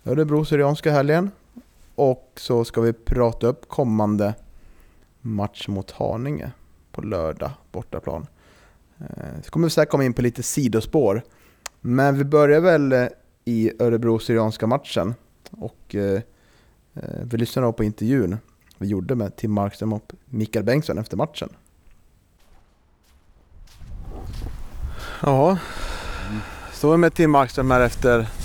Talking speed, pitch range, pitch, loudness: 120 wpm, 100-135 Hz, 115 Hz, -22 LUFS